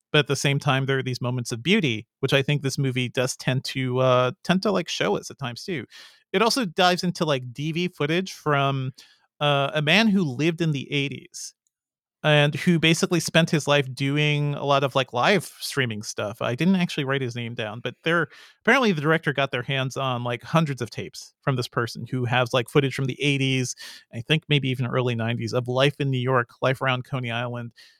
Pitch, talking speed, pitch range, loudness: 140 Hz, 220 wpm, 125-155 Hz, -23 LUFS